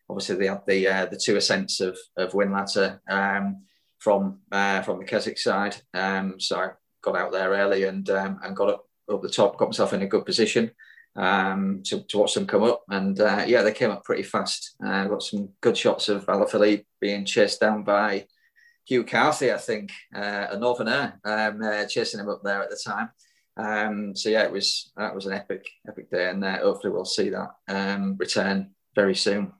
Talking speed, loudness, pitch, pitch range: 210 wpm, -25 LUFS, 100 Hz, 95-105 Hz